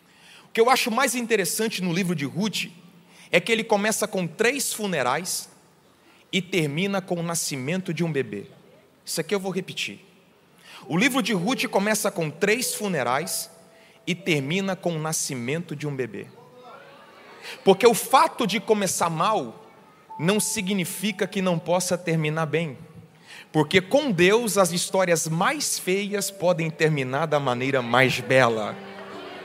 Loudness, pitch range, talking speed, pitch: -23 LUFS, 160-210 Hz, 150 wpm, 185 Hz